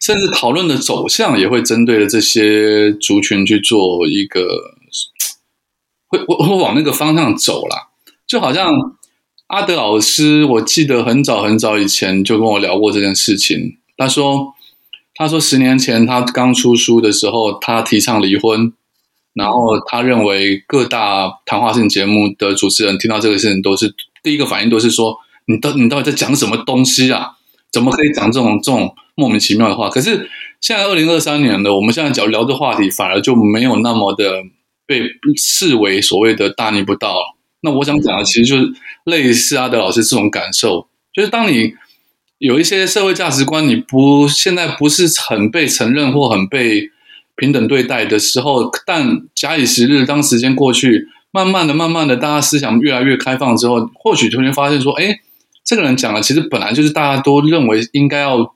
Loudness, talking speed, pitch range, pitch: -12 LUFS, 280 characters per minute, 110-150 Hz, 130 Hz